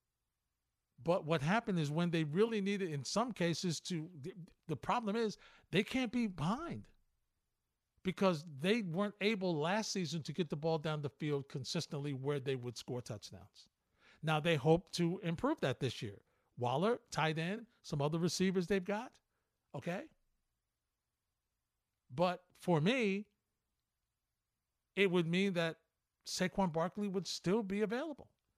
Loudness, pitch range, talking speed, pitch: -37 LUFS, 150-200 Hz, 145 wpm, 175 Hz